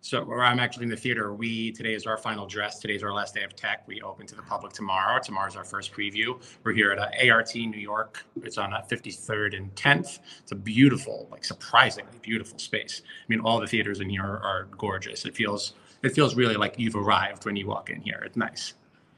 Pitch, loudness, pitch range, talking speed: 110 Hz, -27 LUFS, 100-115 Hz, 230 wpm